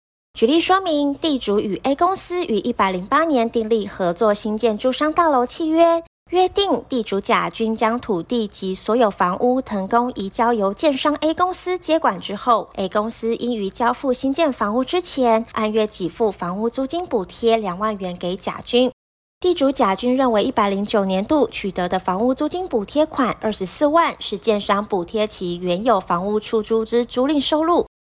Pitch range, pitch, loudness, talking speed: 205-280 Hz, 230 Hz, -19 LUFS, 275 characters per minute